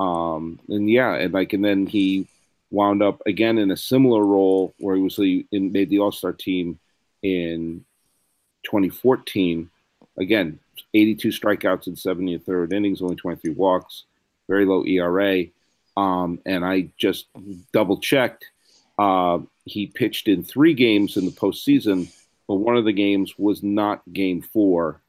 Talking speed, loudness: 160 wpm, -21 LUFS